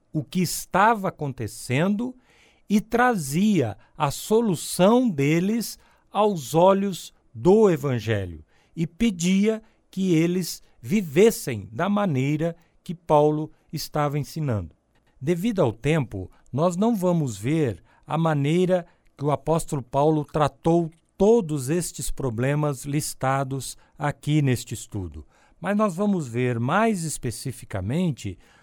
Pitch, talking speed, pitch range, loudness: 155 Hz, 105 wpm, 135-185 Hz, -24 LUFS